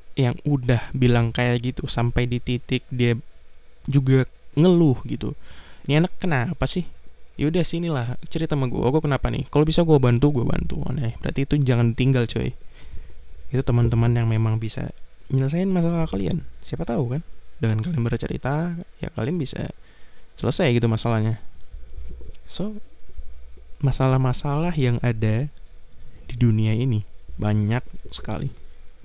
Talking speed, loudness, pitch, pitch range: 140 wpm, -23 LUFS, 125 Hz, 110-145 Hz